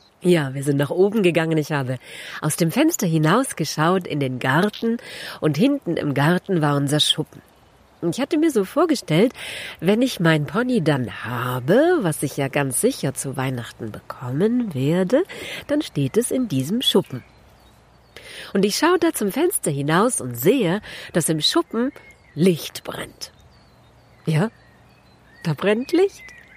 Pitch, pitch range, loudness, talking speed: 170 Hz, 145-235 Hz, -21 LUFS, 150 wpm